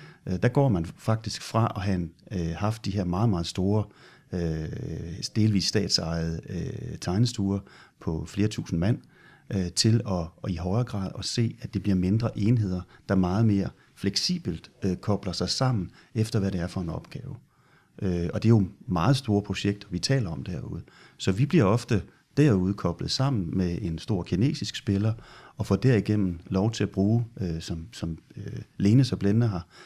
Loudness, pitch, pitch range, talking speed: -27 LUFS, 100 Hz, 90-115 Hz, 165 wpm